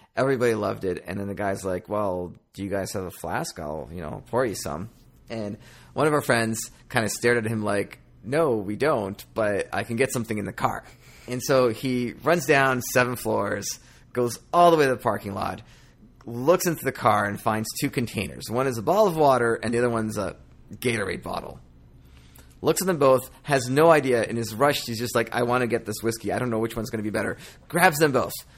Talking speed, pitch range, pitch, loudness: 230 wpm, 105-130 Hz, 115 Hz, -24 LUFS